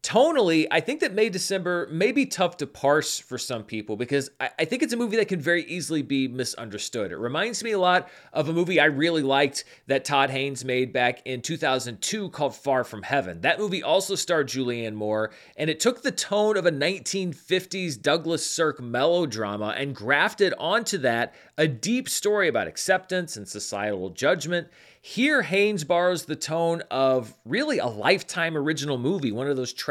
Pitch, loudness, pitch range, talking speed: 155 Hz, -25 LUFS, 130-185 Hz, 185 wpm